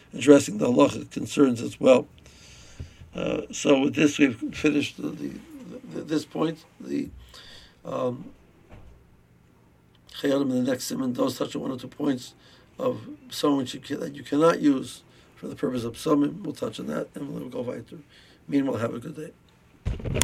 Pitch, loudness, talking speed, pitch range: 145 Hz, -25 LUFS, 165 wpm, 115-155 Hz